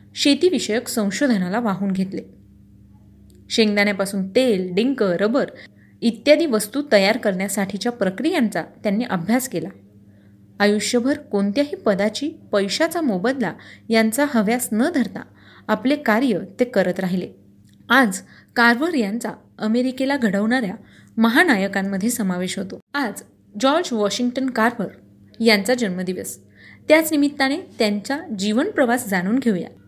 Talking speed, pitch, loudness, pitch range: 100 wpm, 220 Hz, -20 LUFS, 190-255 Hz